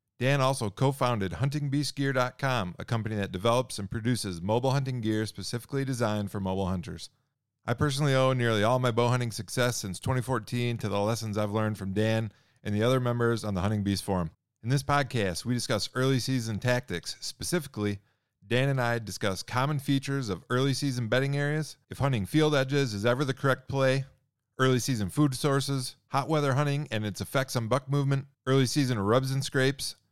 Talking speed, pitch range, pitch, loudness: 185 wpm, 110-135 Hz, 125 Hz, -29 LUFS